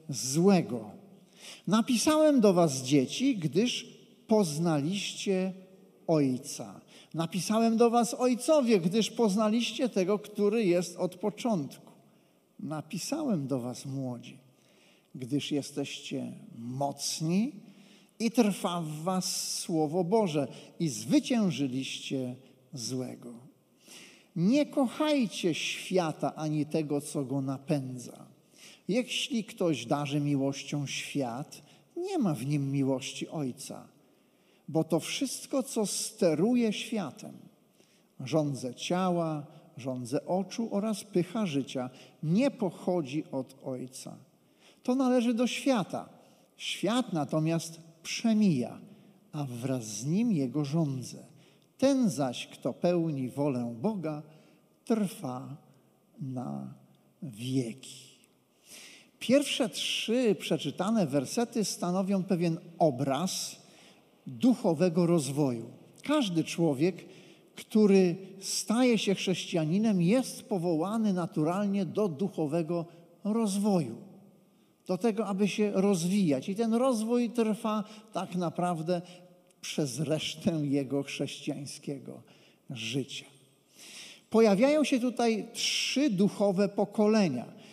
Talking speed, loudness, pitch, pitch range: 95 wpm, -30 LUFS, 180 Hz, 145-215 Hz